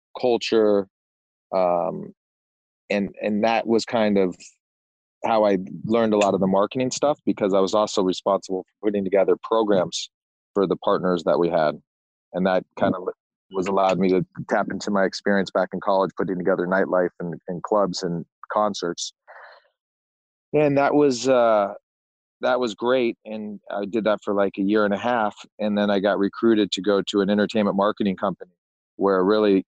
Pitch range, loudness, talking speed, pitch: 95-110 Hz, -22 LUFS, 175 wpm, 100 Hz